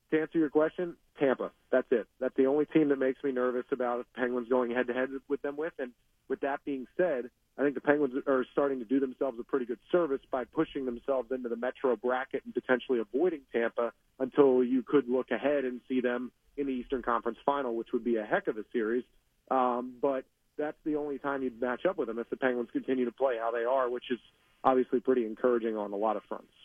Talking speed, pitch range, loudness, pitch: 235 wpm, 125-140 Hz, -31 LUFS, 130 Hz